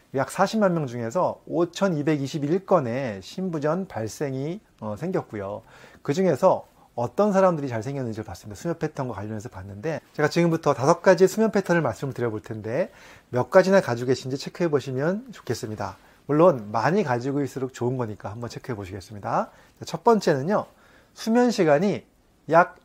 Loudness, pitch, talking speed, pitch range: -24 LUFS, 140 Hz, 345 characters per minute, 115-180 Hz